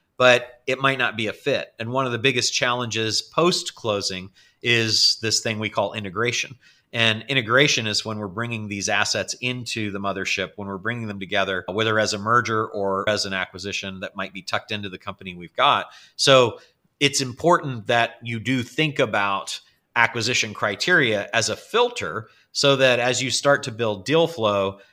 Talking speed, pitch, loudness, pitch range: 185 wpm, 115 Hz, -21 LUFS, 100-125 Hz